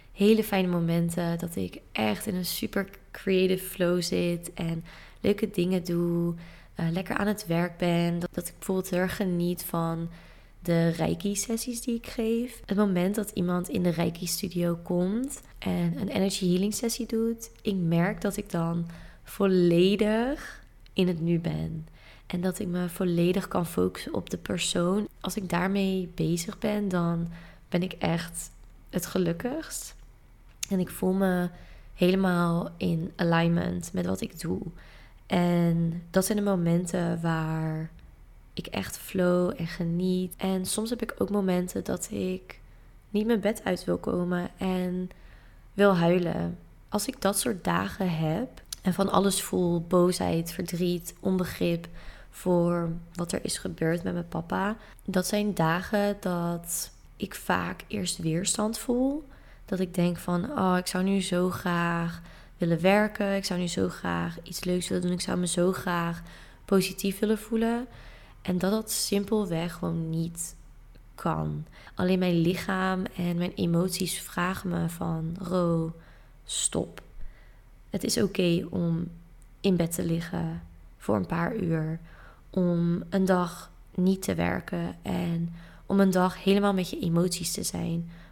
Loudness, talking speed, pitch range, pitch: -28 LUFS, 155 wpm, 170-195 Hz, 180 Hz